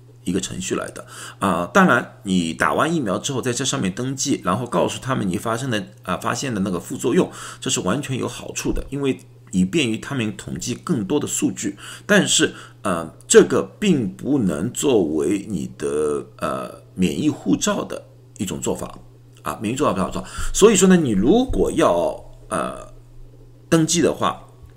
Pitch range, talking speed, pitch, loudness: 95-155 Hz, 260 characters per minute, 125 Hz, -21 LUFS